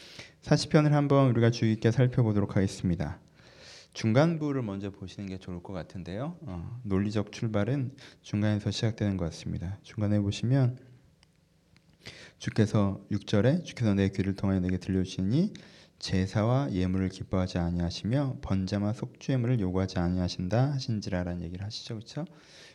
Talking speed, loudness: 345 characters per minute, -29 LUFS